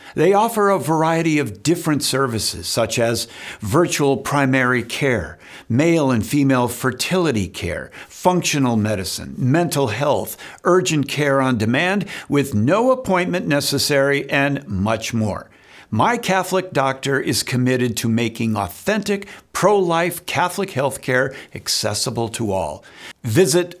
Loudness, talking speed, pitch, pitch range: -19 LUFS, 125 wpm, 135 Hz, 115-170 Hz